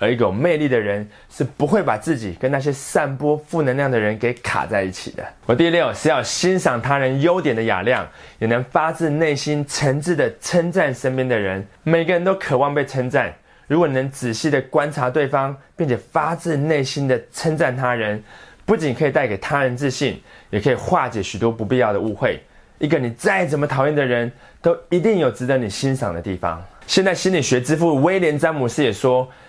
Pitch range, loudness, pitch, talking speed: 120-160 Hz, -19 LUFS, 140 Hz, 305 characters per minute